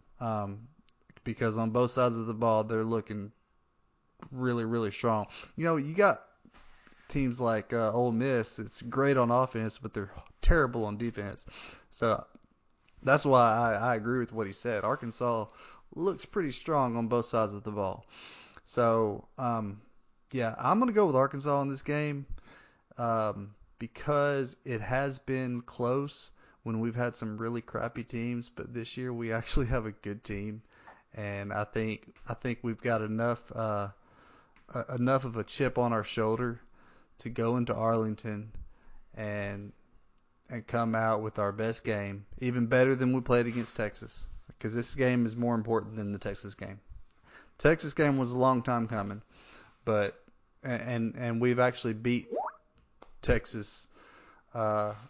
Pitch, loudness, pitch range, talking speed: 115 Hz, -31 LUFS, 110-125 Hz, 160 wpm